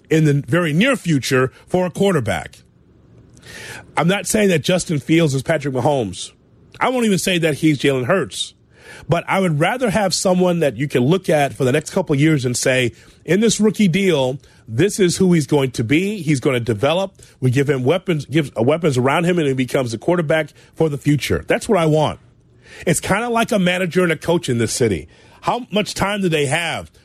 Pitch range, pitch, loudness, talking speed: 135-185 Hz, 155 Hz, -18 LUFS, 215 wpm